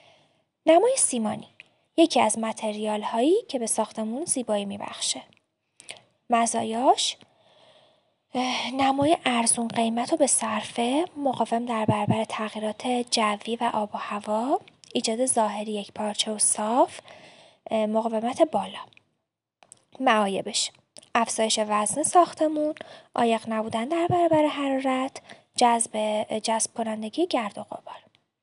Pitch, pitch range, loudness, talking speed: 235 Hz, 220-300 Hz, -25 LUFS, 105 wpm